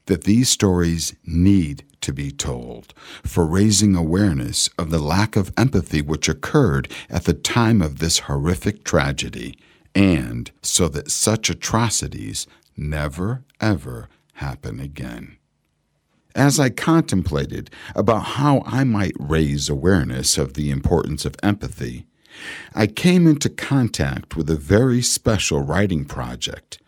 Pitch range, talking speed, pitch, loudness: 75-110 Hz, 125 wpm, 90 Hz, -20 LUFS